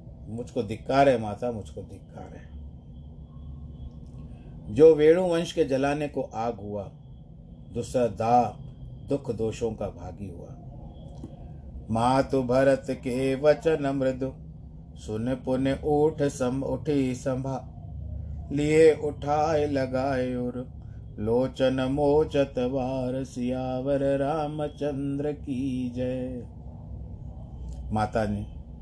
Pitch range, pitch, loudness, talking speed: 105-140 Hz, 130 Hz, -26 LUFS, 95 wpm